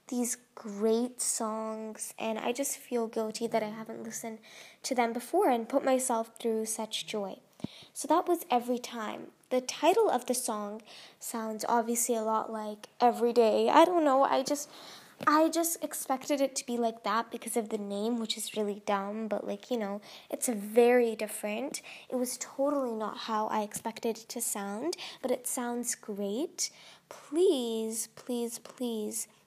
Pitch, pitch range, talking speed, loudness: 235 Hz, 220-260 Hz, 170 wpm, -31 LUFS